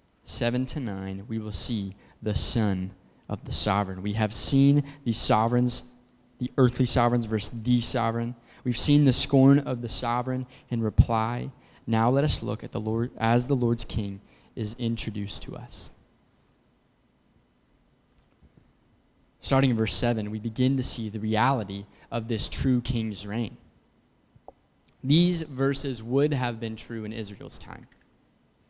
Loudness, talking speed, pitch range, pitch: -26 LUFS, 145 wpm, 110-130 Hz, 120 Hz